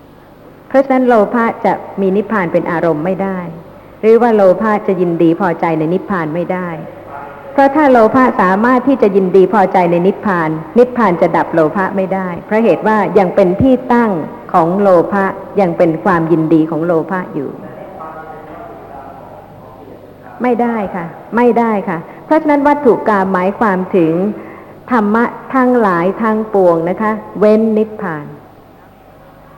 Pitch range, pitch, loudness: 175-220 Hz, 195 Hz, -12 LUFS